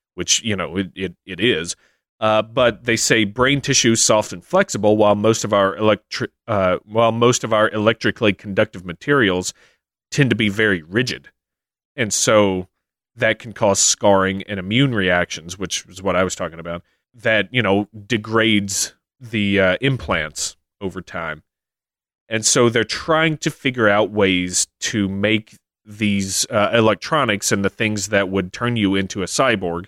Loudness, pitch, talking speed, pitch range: -18 LUFS, 105 Hz, 165 wpm, 95-115 Hz